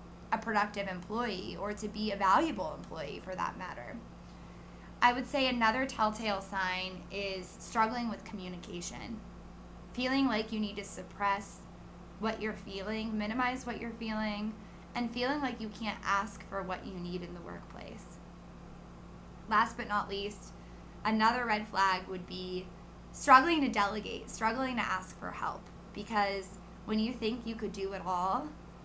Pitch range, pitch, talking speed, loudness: 190-225 Hz, 210 Hz, 155 wpm, -33 LUFS